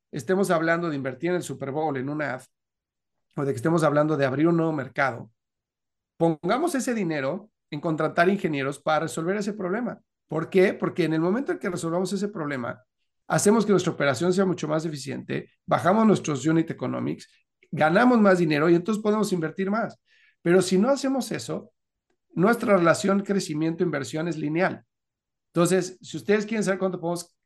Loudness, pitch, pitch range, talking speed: -24 LUFS, 170 Hz, 150-195 Hz, 175 wpm